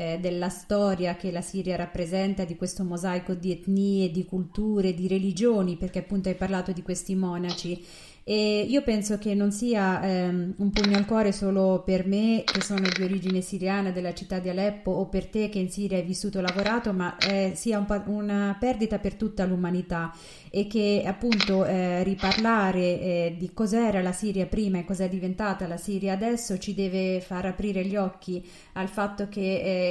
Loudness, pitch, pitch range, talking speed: -27 LUFS, 190 Hz, 185-205 Hz, 185 wpm